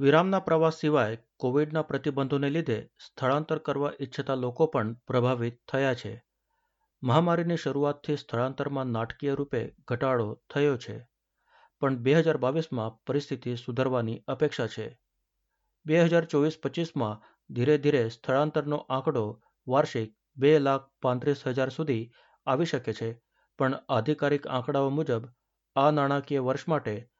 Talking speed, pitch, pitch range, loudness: 120 wpm, 140 Hz, 125-150 Hz, -28 LUFS